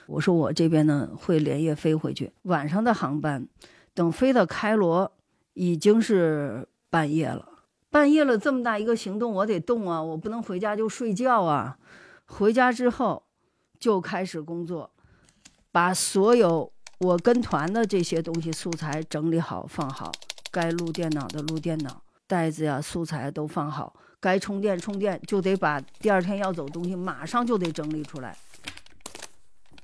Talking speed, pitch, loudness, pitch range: 240 characters per minute, 175 Hz, -25 LUFS, 160-210 Hz